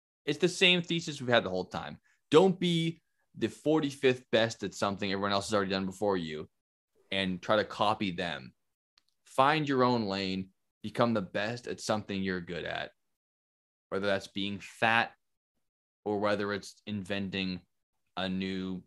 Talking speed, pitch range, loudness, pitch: 160 wpm, 95-120 Hz, -31 LUFS, 100 Hz